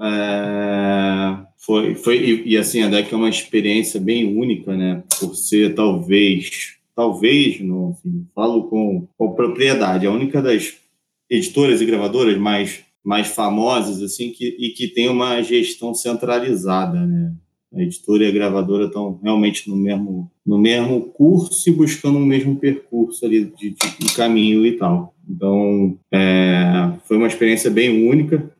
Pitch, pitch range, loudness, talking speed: 110 Hz, 100-125 Hz, -17 LUFS, 155 wpm